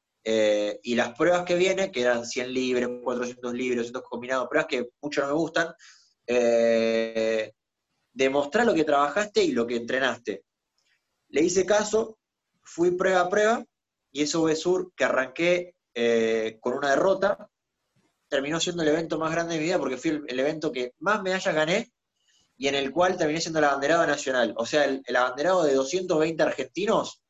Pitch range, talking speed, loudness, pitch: 125-180 Hz, 175 wpm, -25 LUFS, 150 Hz